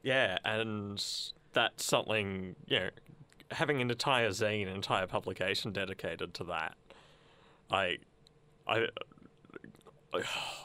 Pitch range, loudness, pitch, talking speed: 95-120 Hz, -34 LUFS, 105 Hz, 115 wpm